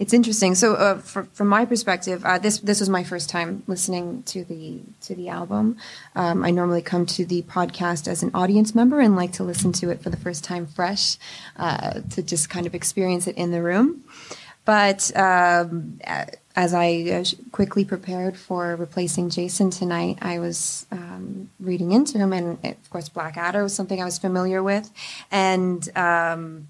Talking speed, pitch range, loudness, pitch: 185 wpm, 175-200 Hz, -22 LUFS, 180 Hz